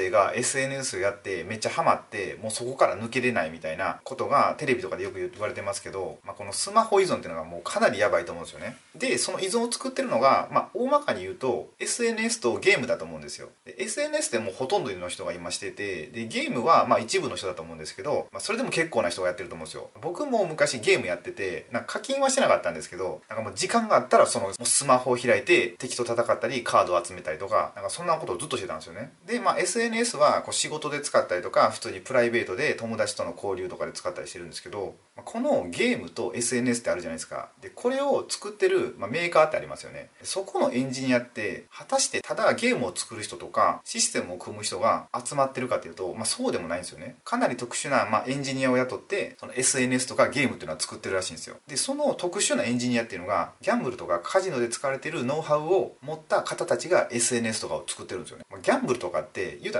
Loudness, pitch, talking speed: -26 LUFS, 190 Hz, 530 characters per minute